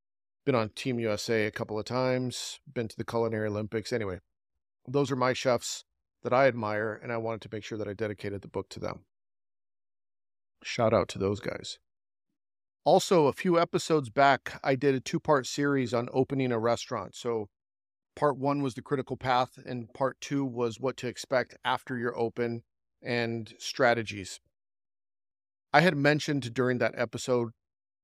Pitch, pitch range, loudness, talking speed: 120 Hz, 105-130 Hz, -29 LUFS, 170 wpm